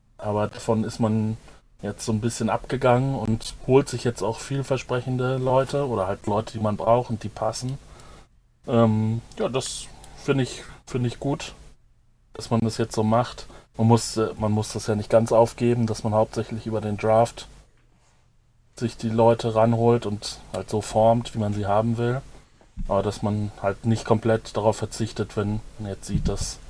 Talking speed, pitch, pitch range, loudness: 180 wpm, 115 Hz, 110-120 Hz, -24 LUFS